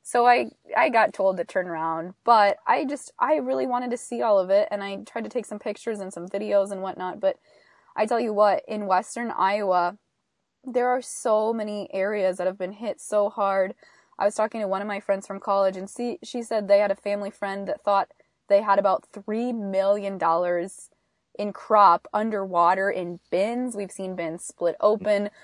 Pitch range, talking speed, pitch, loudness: 190-225 Hz, 205 wpm, 205 Hz, -24 LUFS